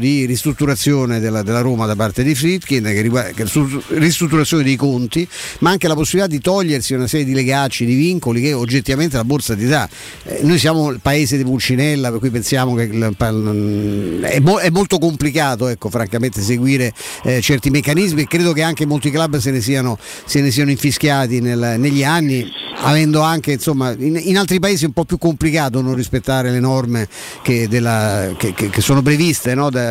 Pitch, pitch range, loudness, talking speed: 135 Hz, 120-155 Hz, -16 LUFS, 195 wpm